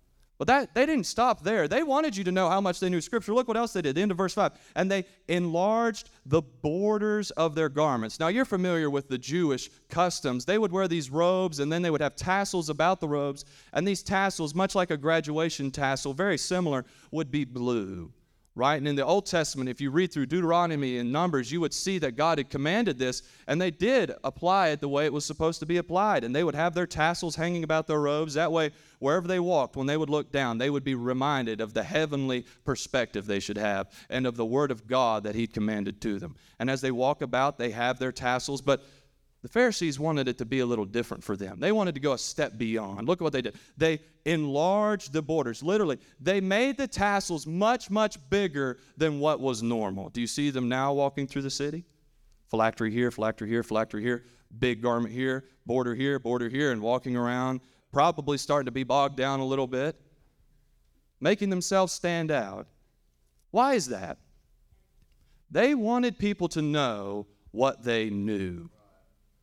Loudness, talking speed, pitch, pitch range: -28 LUFS, 210 wpm, 145 Hz, 125-175 Hz